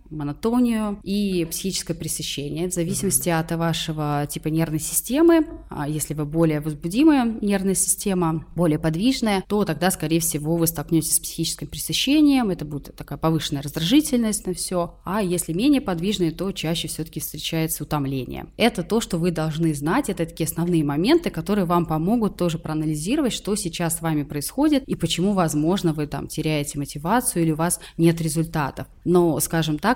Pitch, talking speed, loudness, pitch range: 165 Hz, 160 wpm, -22 LUFS, 155-195 Hz